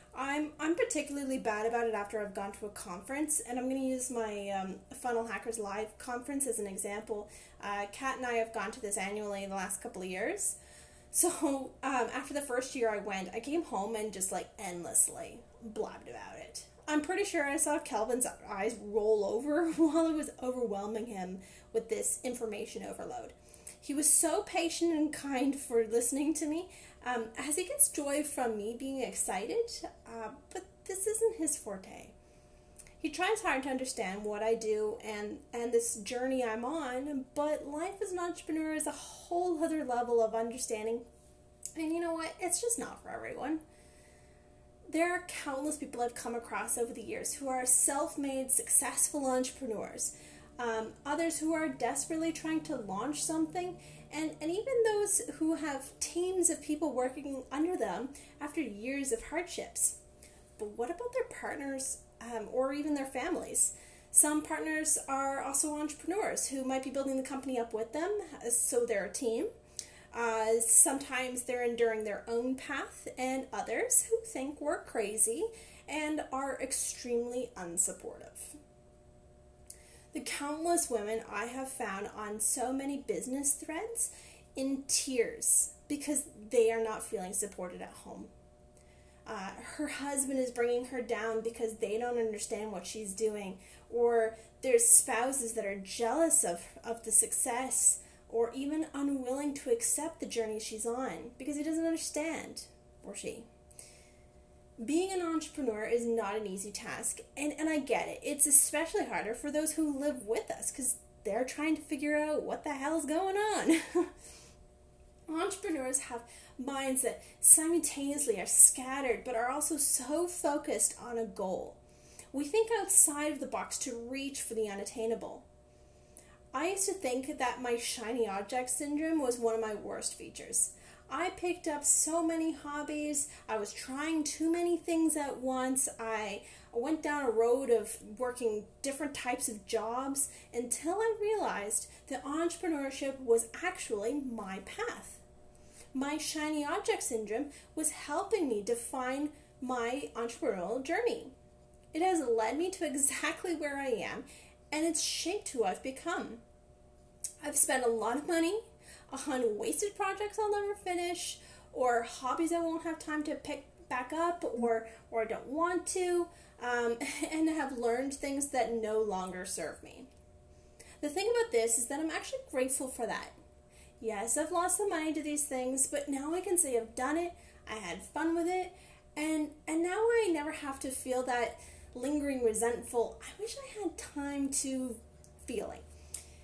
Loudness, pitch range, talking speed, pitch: -32 LUFS, 230-315 Hz, 165 wpm, 270 Hz